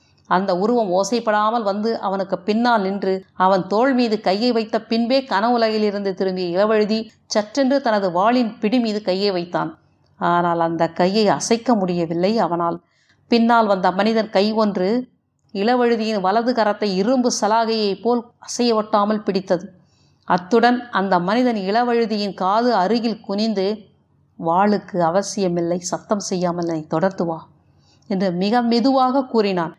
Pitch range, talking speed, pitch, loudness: 185-230 Hz, 115 wpm, 205 Hz, -19 LUFS